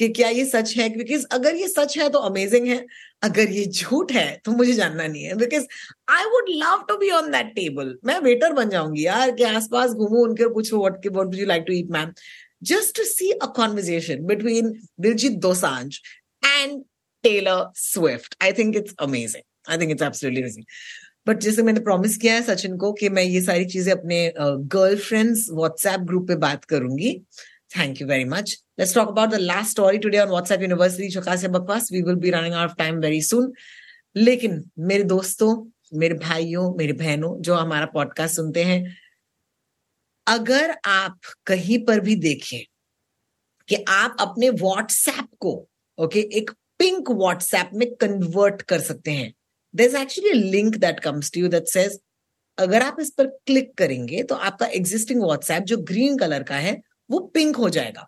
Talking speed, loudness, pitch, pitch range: 155 wpm, -21 LUFS, 200 Hz, 175-235 Hz